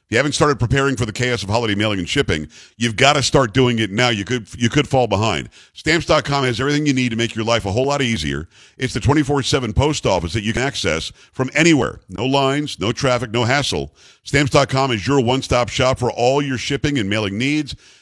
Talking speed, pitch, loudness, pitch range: 225 wpm, 130 Hz, -18 LUFS, 115-140 Hz